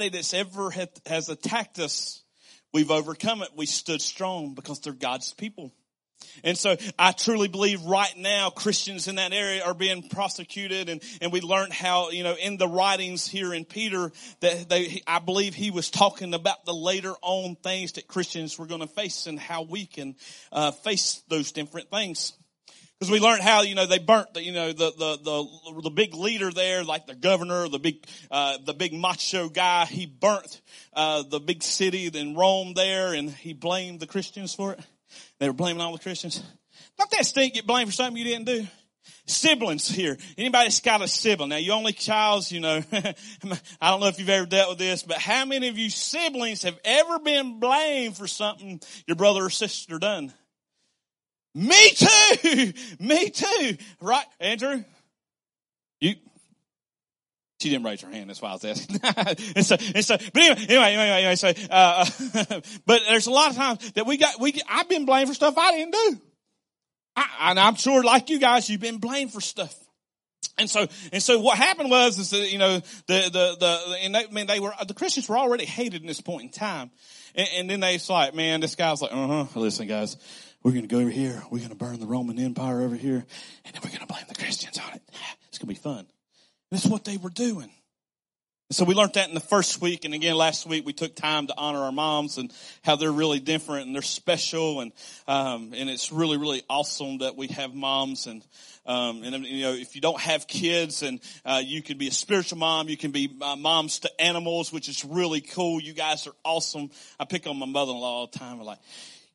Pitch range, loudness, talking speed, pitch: 155-210 Hz, -24 LUFS, 210 wpm, 180 Hz